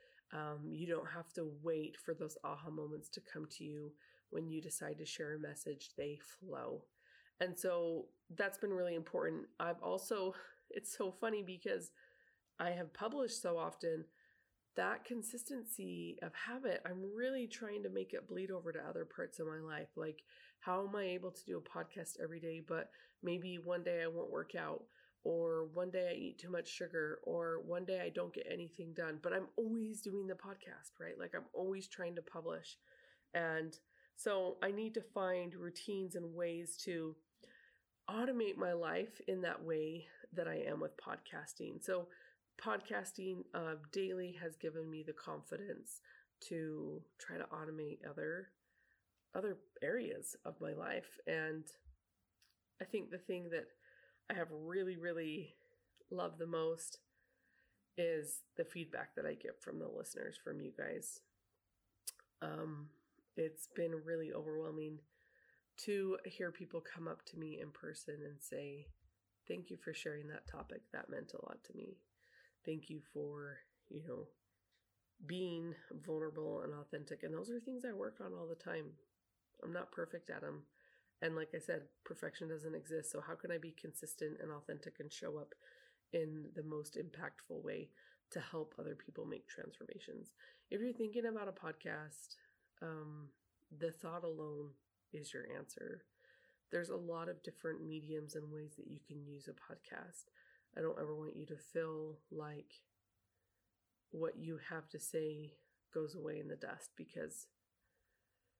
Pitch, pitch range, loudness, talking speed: 165 Hz, 155-185 Hz, -45 LUFS, 165 wpm